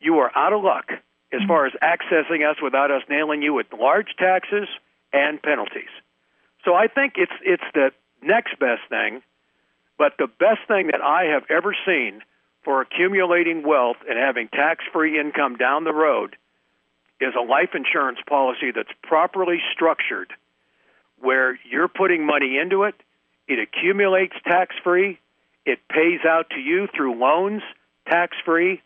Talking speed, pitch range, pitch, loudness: 155 wpm, 130-185 Hz, 160 Hz, -20 LUFS